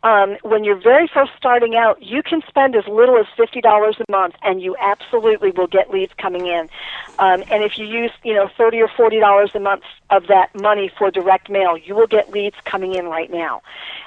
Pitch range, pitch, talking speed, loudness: 190-230 Hz, 205 Hz, 225 wpm, -16 LUFS